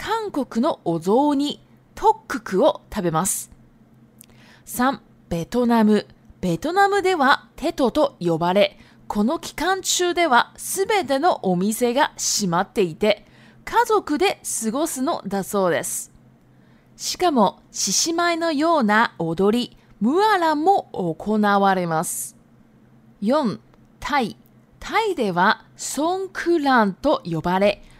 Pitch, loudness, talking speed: 240 Hz, -21 LUFS, 210 characters per minute